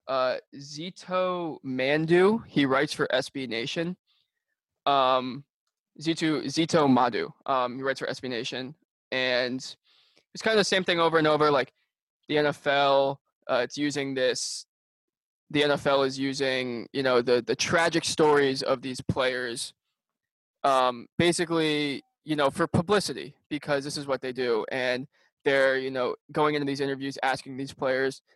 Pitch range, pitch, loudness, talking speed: 130-160 Hz, 140 Hz, -26 LUFS, 150 wpm